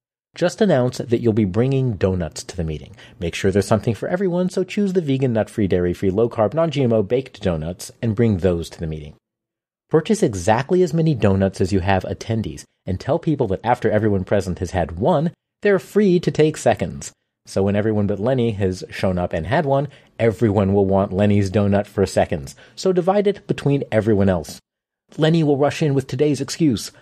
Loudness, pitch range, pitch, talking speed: -20 LUFS, 100-150 Hz, 115 Hz, 200 wpm